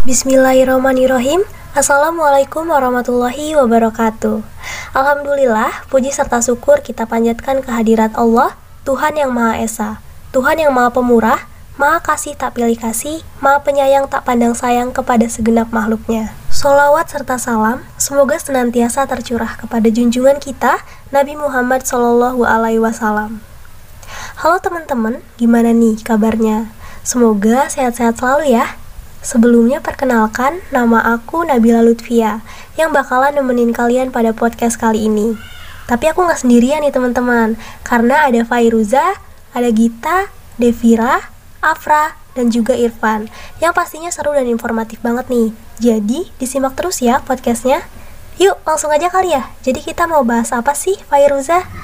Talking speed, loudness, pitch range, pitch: 125 wpm, -14 LUFS, 230-285 Hz, 250 Hz